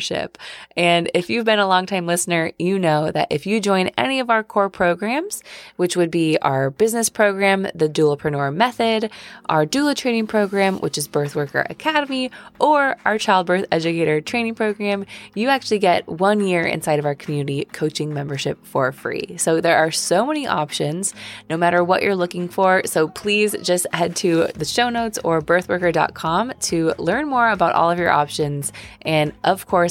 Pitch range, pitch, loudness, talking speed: 160-215 Hz, 180 Hz, -19 LUFS, 180 wpm